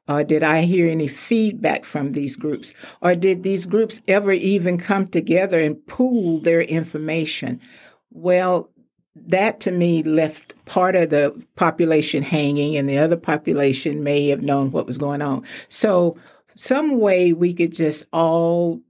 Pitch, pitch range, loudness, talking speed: 165 Hz, 150-180 Hz, -19 LUFS, 160 wpm